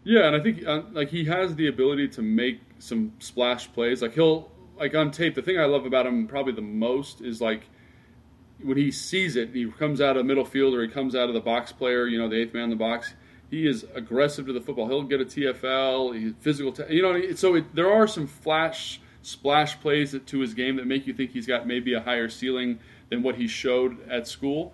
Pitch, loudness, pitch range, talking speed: 130 Hz, -25 LUFS, 120-150 Hz, 240 wpm